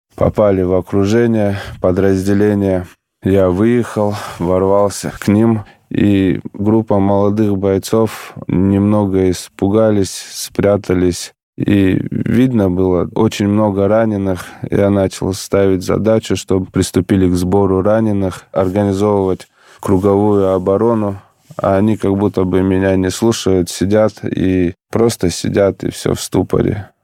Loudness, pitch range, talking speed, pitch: -14 LUFS, 95-105 Hz, 110 wpm, 100 Hz